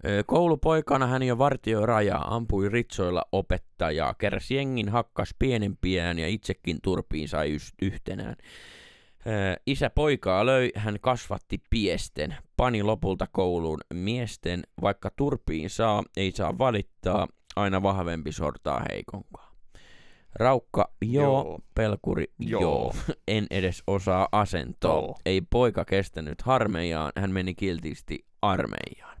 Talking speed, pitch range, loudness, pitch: 105 wpm, 90-115 Hz, -27 LUFS, 100 Hz